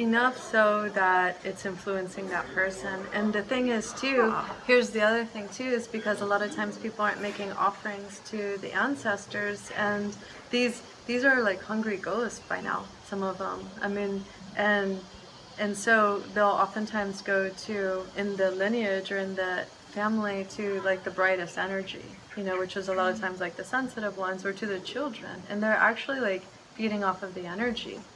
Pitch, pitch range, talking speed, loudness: 205 Hz, 190-215 Hz, 190 wpm, -29 LUFS